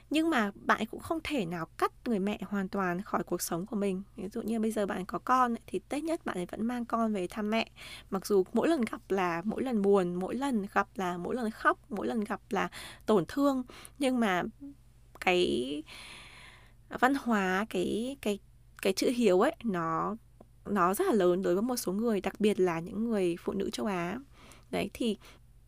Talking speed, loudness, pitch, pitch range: 210 wpm, -31 LUFS, 200 Hz, 180-230 Hz